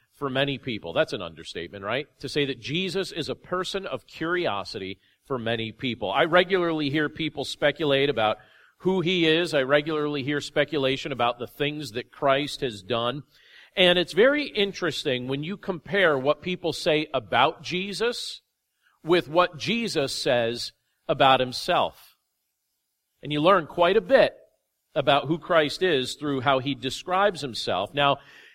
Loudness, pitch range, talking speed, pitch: -25 LUFS, 130-175 Hz, 155 wpm, 145 Hz